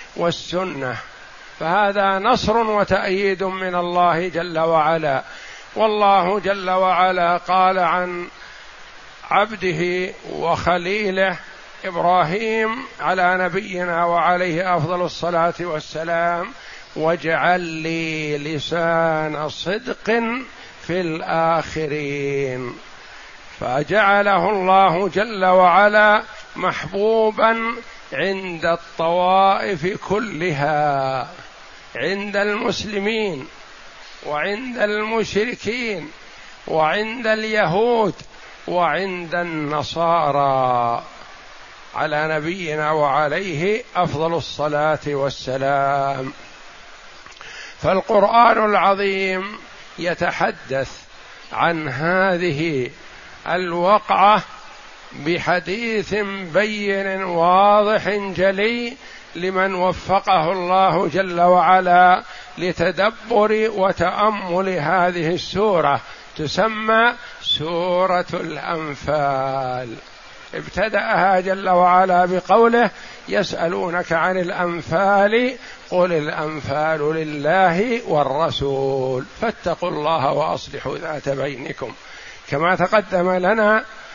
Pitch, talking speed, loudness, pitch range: 180 Hz, 65 wpm, -19 LUFS, 160-200 Hz